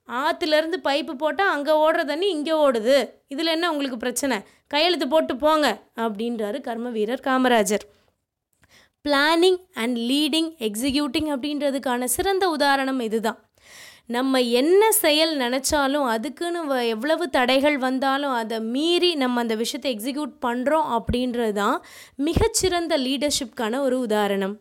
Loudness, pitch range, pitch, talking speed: -22 LUFS, 245-315 Hz, 280 Hz, 115 wpm